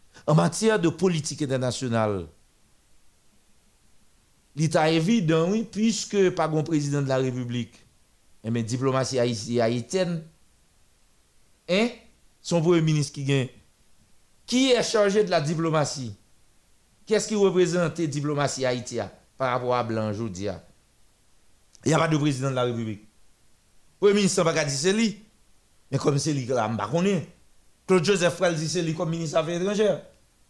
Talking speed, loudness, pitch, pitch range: 150 wpm, -25 LUFS, 155 Hz, 120-180 Hz